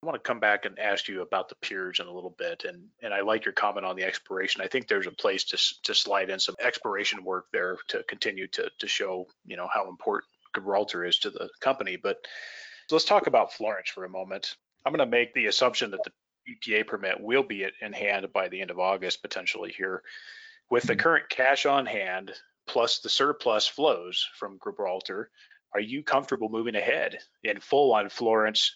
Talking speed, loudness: 210 wpm, -28 LUFS